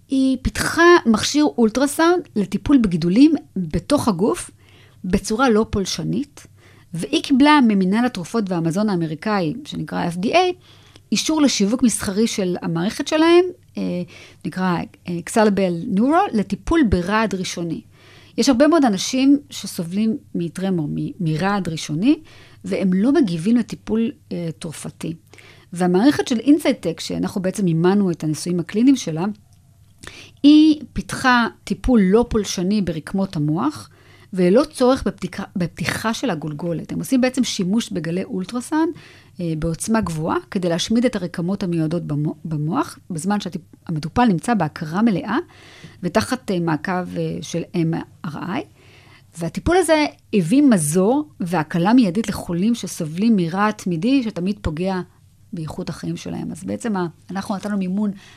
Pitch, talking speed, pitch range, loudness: 195 Hz, 115 wpm, 170-240 Hz, -20 LUFS